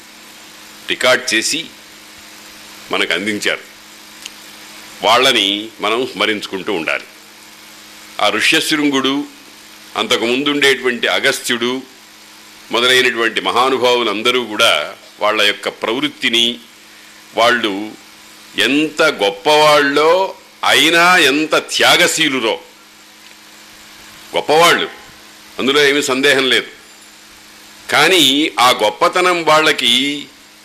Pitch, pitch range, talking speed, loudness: 120 Hz, 105-145 Hz, 70 wpm, -13 LUFS